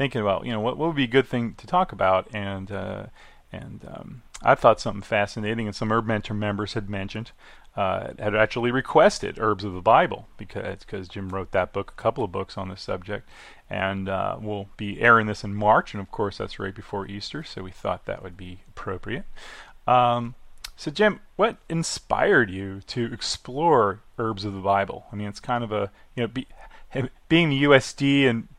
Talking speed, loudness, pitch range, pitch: 200 wpm, -24 LUFS, 100-125 Hz, 110 Hz